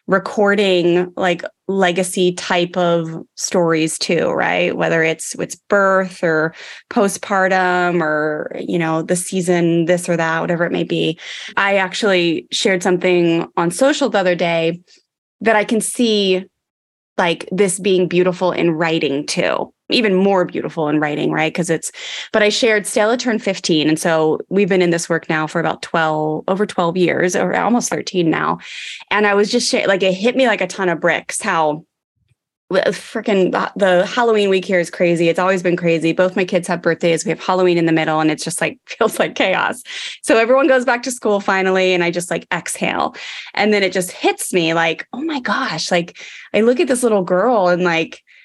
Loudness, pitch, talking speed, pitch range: -17 LUFS, 180 Hz, 190 wpm, 170-200 Hz